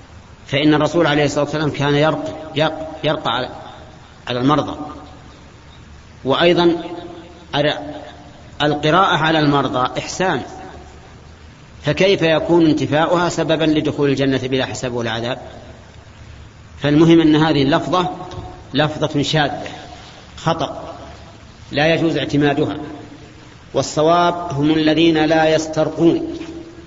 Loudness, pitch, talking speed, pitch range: -17 LUFS, 150 Hz, 90 wpm, 135-160 Hz